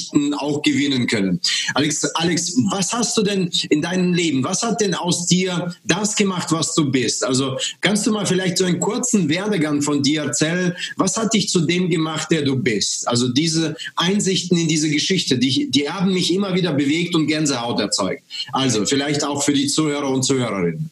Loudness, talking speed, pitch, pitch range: -19 LUFS, 190 wpm, 160 Hz, 145-185 Hz